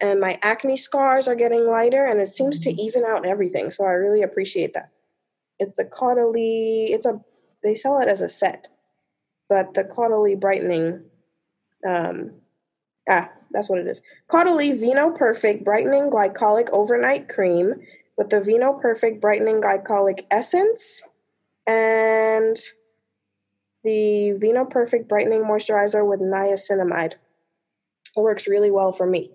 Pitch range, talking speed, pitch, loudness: 195-240 Hz, 140 wpm, 215 Hz, -20 LUFS